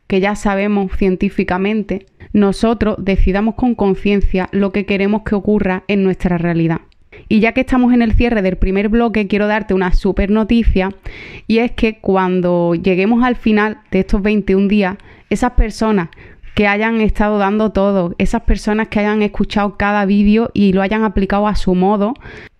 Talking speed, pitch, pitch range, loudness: 165 wpm, 205 Hz, 195-215 Hz, -15 LUFS